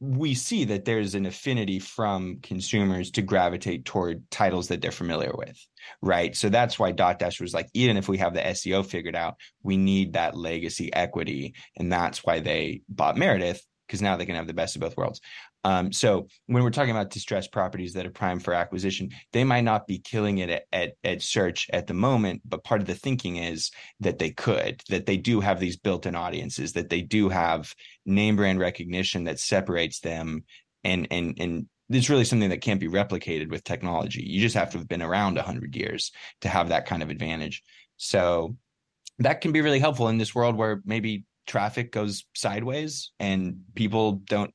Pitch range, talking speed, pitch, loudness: 90-110 Hz, 200 wpm, 95 Hz, -26 LUFS